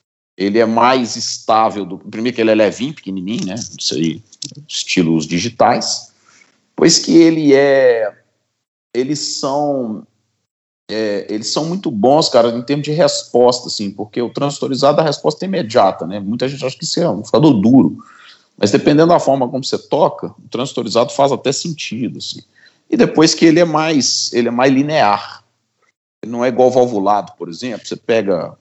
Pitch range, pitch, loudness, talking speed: 105-145 Hz, 125 Hz, -15 LUFS, 170 wpm